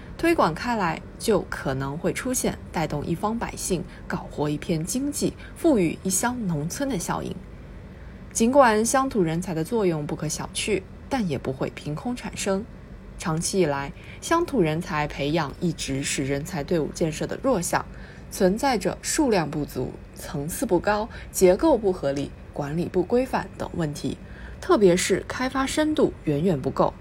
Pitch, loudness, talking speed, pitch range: 180 Hz, -25 LUFS, 240 characters per minute, 150-225 Hz